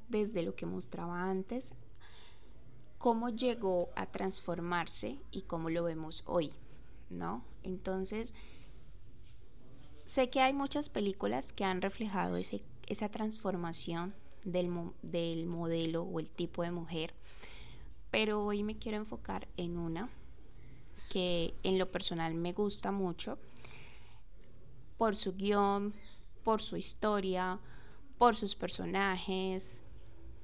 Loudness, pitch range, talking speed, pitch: -36 LUFS, 170-210 Hz, 115 wpm, 185 Hz